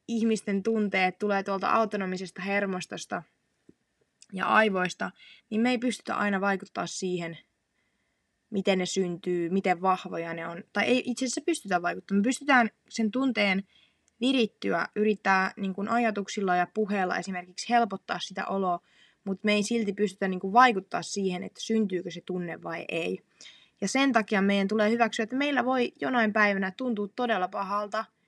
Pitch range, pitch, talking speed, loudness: 190-230 Hz, 200 Hz, 150 wpm, -28 LUFS